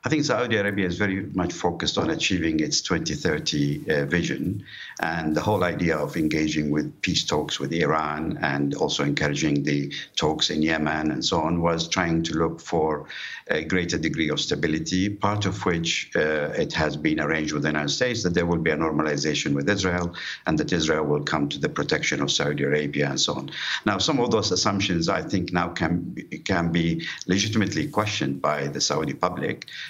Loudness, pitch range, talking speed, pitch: -24 LUFS, 75-95 Hz, 195 wpm, 85 Hz